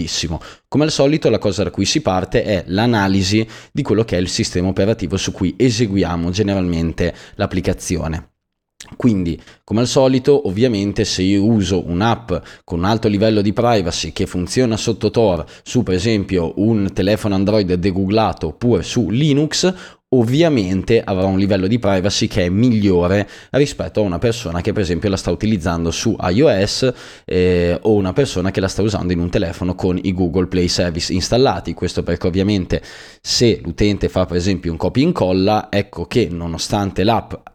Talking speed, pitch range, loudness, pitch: 170 wpm, 90-110 Hz, -17 LUFS, 100 Hz